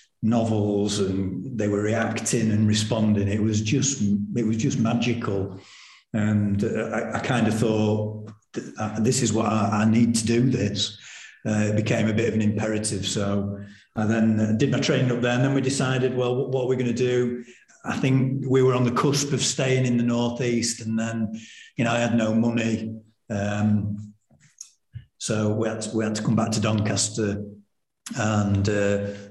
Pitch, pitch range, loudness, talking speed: 110 Hz, 105-120 Hz, -24 LUFS, 185 wpm